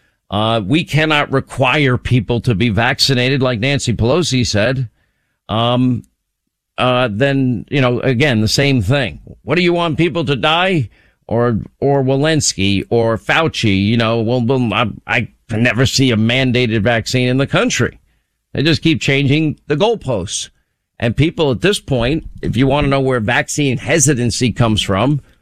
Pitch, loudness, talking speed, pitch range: 130 Hz, -15 LUFS, 160 wpm, 115-145 Hz